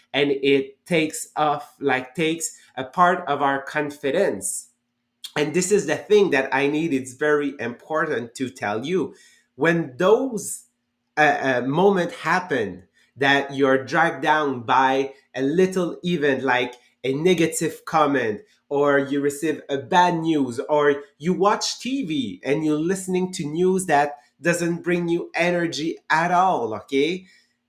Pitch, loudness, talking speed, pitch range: 150 Hz, -22 LUFS, 145 wpm, 135-175 Hz